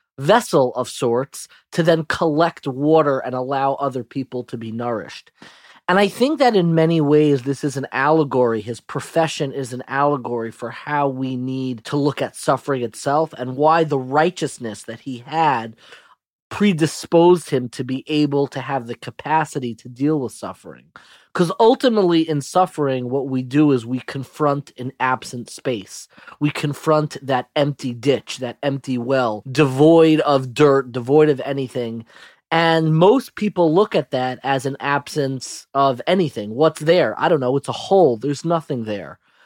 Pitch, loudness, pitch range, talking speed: 140 Hz, -19 LUFS, 130-155 Hz, 165 wpm